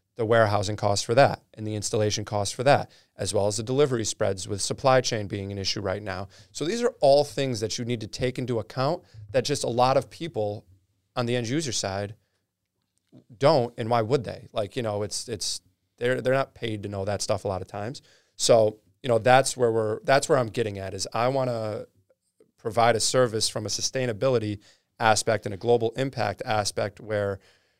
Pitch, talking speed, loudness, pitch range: 110 Hz, 210 wpm, -25 LUFS, 105-125 Hz